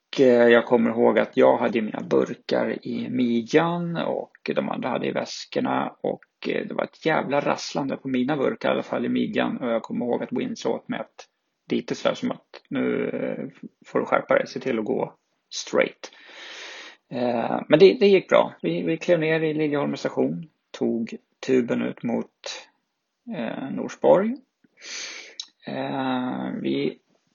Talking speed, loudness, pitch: 155 wpm, -24 LUFS, 135 Hz